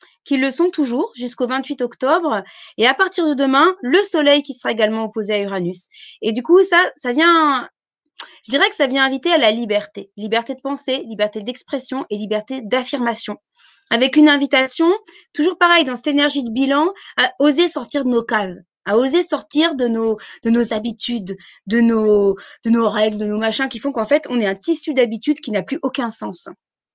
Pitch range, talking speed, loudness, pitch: 220-295 Hz, 200 wpm, -17 LUFS, 260 Hz